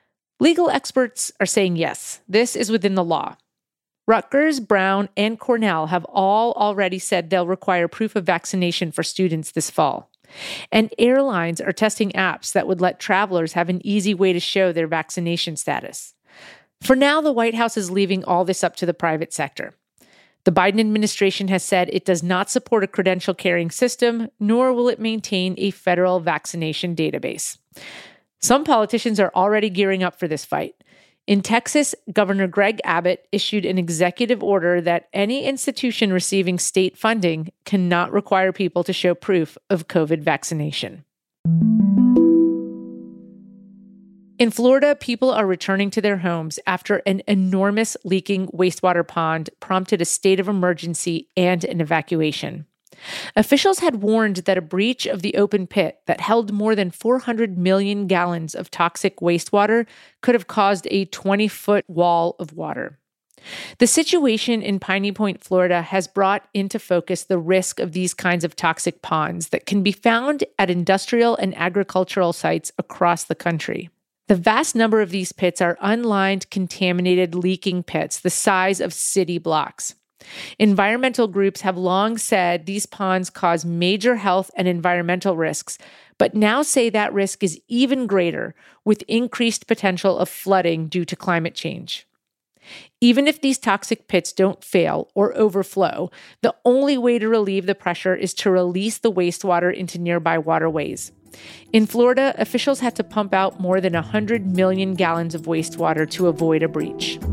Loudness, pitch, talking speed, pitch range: -20 LUFS, 190 Hz, 160 wpm, 175-215 Hz